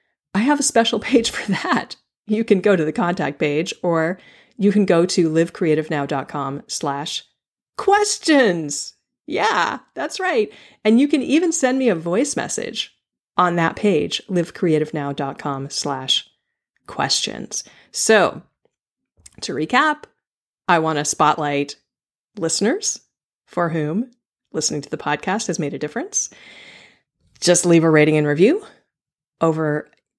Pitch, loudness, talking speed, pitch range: 175 Hz, -19 LUFS, 130 wpm, 150-240 Hz